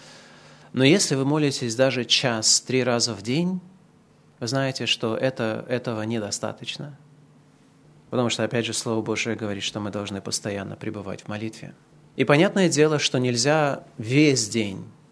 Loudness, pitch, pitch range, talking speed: -23 LUFS, 125 Hz, 115-145 Hz, 145 wpm